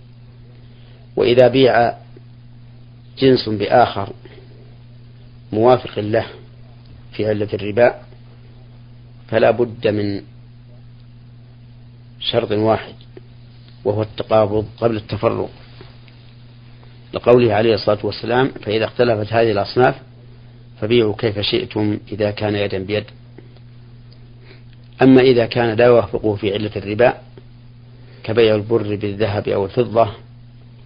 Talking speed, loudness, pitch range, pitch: 90 wpm, -17 LUFS, 110-120 Hz, 120 Hz